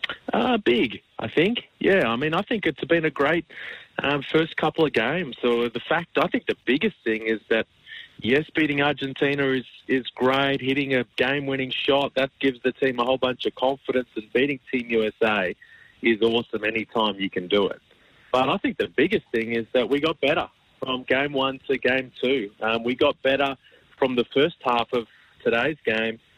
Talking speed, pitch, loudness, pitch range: 200 wpm, 130 Hz, -24 LUFS, 120-140 Hz